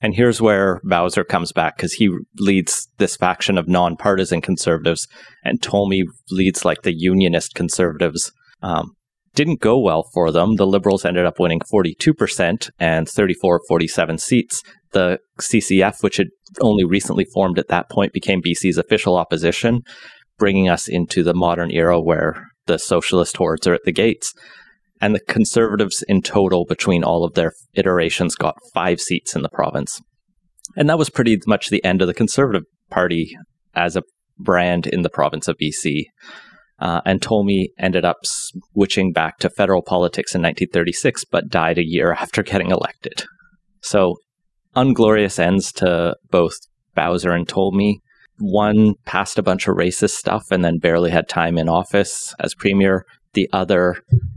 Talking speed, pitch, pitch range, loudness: 160 wpm, 95 Hz, 85-105 Hz, -18 LUFS